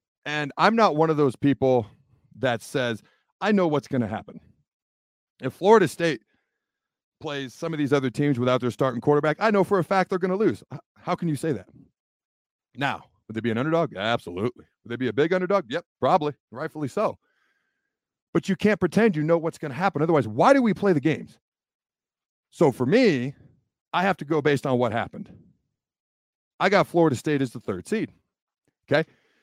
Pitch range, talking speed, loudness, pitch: 130-185 Hz, 195 wpm, -24 LUFS, 150 Hz